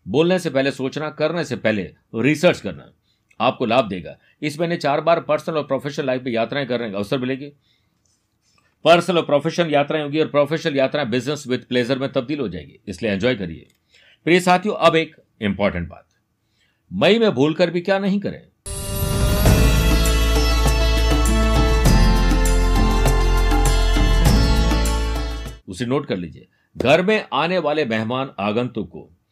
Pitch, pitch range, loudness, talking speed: 135 Hz, 100-160 Hz, -19 LUFS, 140 wpm